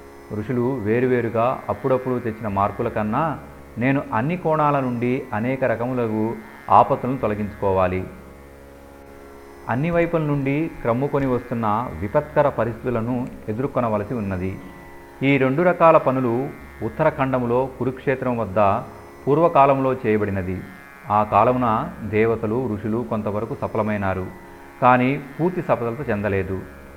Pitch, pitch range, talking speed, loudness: 115 Hz, 105-130 Hz, 95 wpm, -21 LUFS